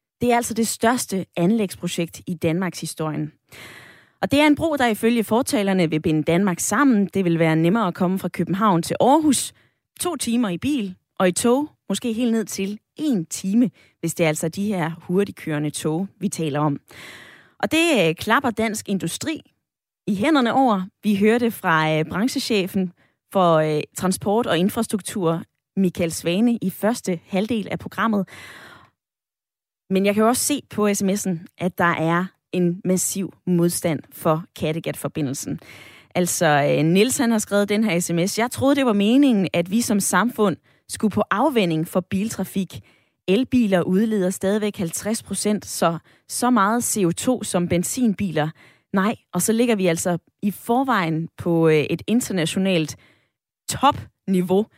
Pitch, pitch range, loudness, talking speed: 190 Hz, 170-225 Hz, -21 LUFS, 150 wpm